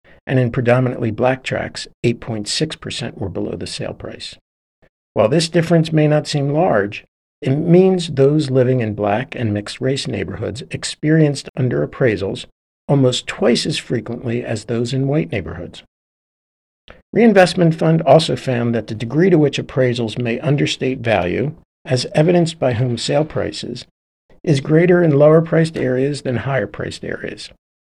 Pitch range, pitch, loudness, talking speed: 120-155 Hz, 130 Hz, -17 LUFS, 150 wpm